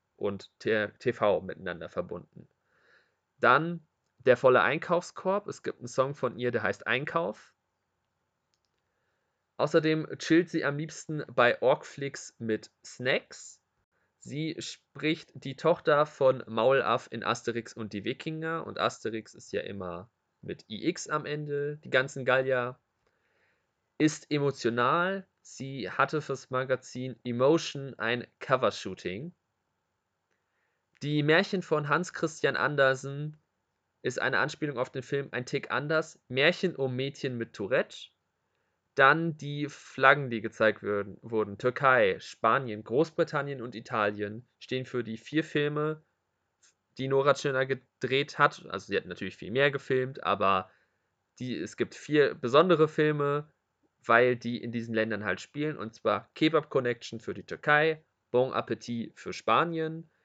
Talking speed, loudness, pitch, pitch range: 130 wpm, -29 LUFS, 135 Hz, 120-150 Hz